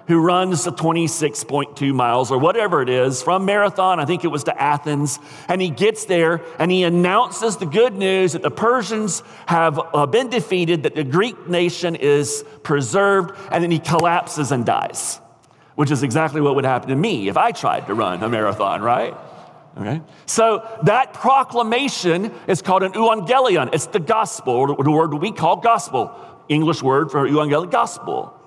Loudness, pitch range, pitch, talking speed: -18 LUFS, 150-195 Hz, 170 Hz, 175 wpm